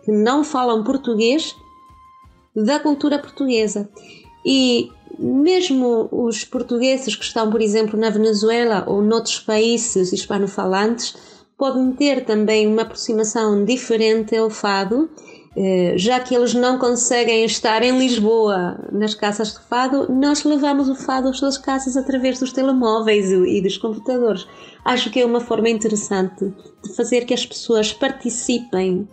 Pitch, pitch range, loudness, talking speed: 230 Hz, 215-260 Hz, -18 LUFS, 135 wpm